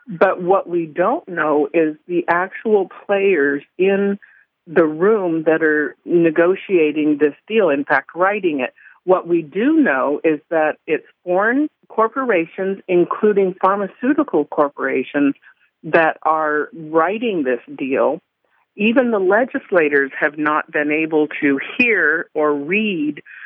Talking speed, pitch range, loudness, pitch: 125 wpm, 150-200 Hz, -18 LUFS, 175 Hz